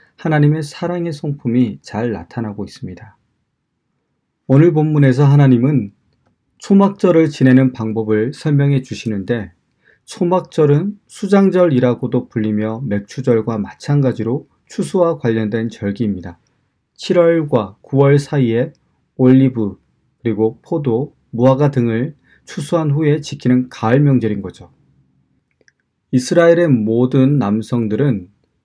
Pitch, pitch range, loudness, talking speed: 130 Hz, 110-150 Hz, -15 LUFS, 260 characters per minute